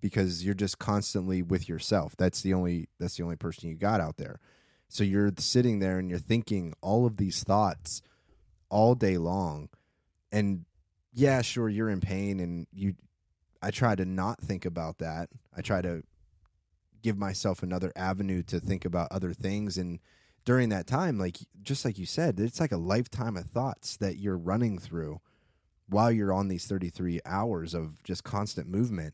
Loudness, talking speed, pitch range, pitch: -30 LUFS, 180 wpm, 85-105 Hz, 95 Hz